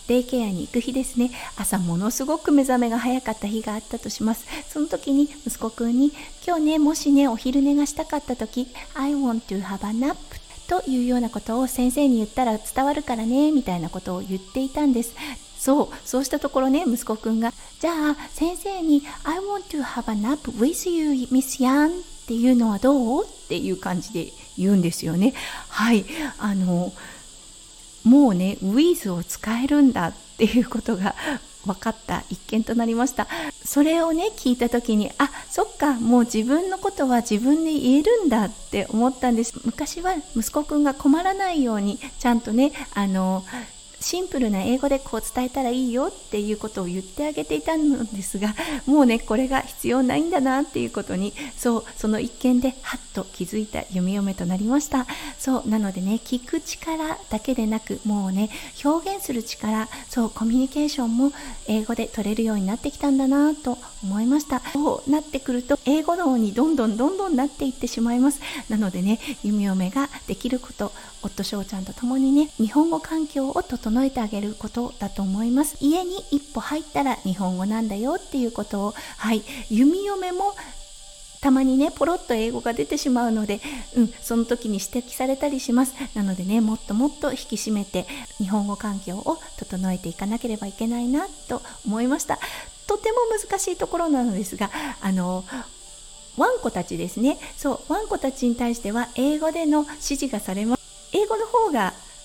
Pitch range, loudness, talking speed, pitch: 220-290 Hz, -23 LUFS, 375 characters per minute, 250 Hz